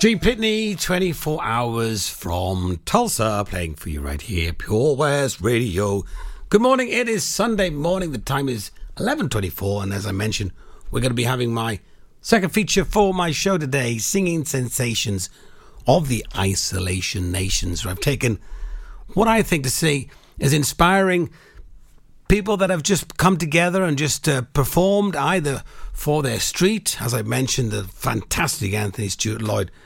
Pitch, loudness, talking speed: 130 Hz, -21 LUFS, 160 wpm